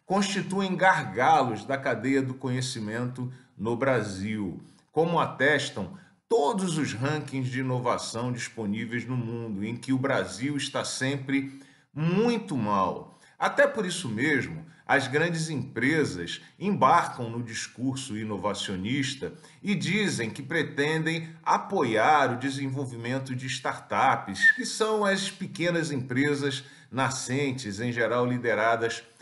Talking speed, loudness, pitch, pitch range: 115 wpm, -27 LUFS, 135 Hz, 120-160 Hz